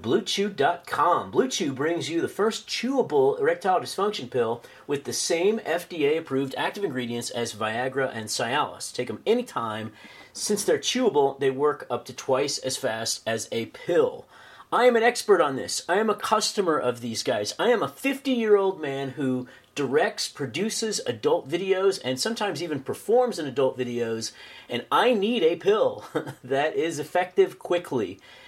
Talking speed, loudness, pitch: 165 wpm, -25 LUFS, 175 Hz